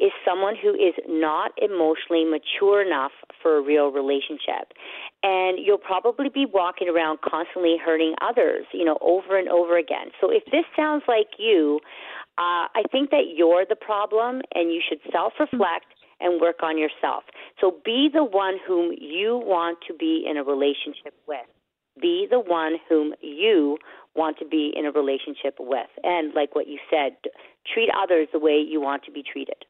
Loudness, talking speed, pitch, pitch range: -23 LUFS, 180 wpm, 175 Hz, 155-250 Hz